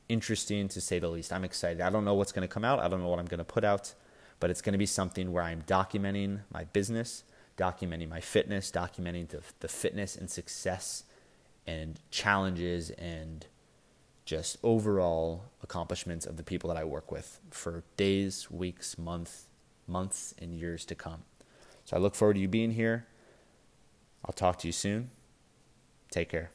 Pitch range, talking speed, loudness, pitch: 85-100 Hz, 185 wpm, -33 LUFS, 90 Hz